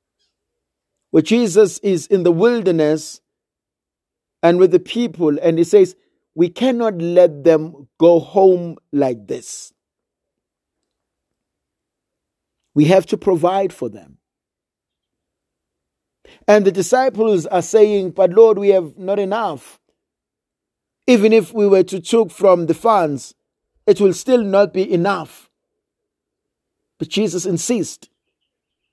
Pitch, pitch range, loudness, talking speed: 190 Hz, 165-210 Hz, -15 LUFS, 115 wpm